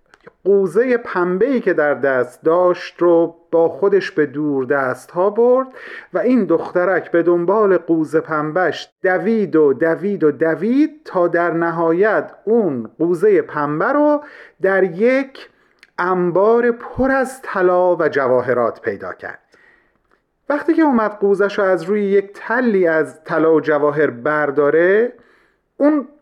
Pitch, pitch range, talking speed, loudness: 185 Hz, 165-235 Hz, 135 wpm, -17 LUFS